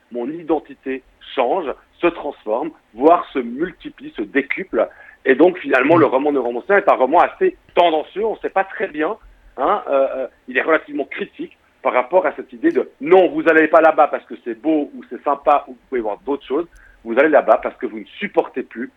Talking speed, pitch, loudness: 210 wpm, 175 Hz, -18 LUFS